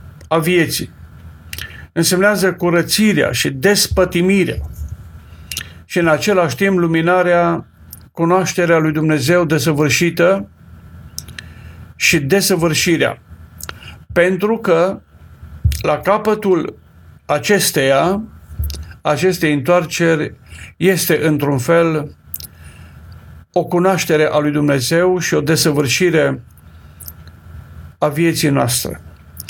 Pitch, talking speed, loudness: 150 Hz, 75 wpm, -15 LUFS